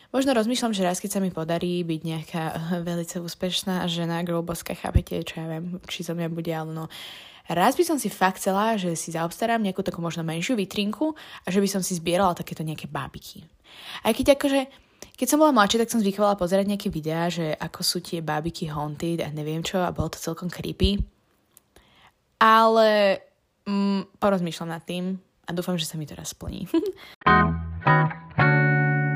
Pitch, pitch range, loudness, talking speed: 180 Hz, 165-205 Hz, -24 LUFS, 180 wpm